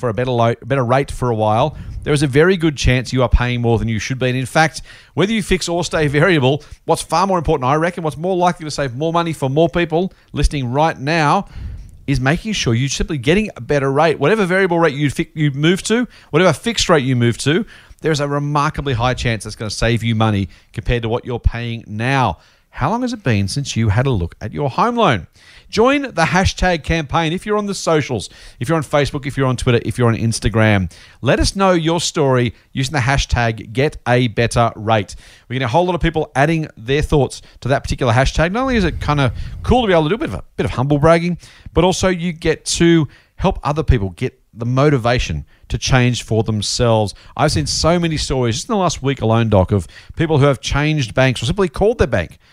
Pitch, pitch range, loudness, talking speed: 140 Hz, 115-165 Hz, -17 LUFS, 240 wpm